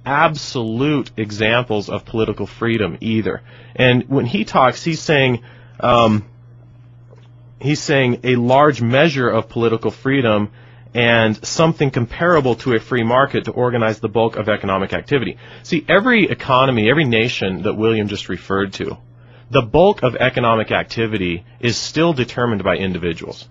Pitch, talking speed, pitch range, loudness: 120 Hz, 140 wpm, 110-130 Hz, -17 LUFS